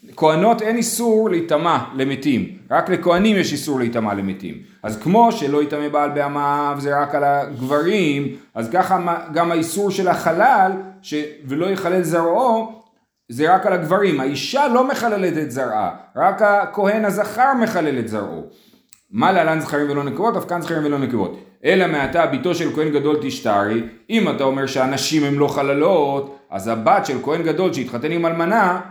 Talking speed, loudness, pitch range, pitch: 165 wpm, -18 LUFS, 140-195 Hz, 160 Hz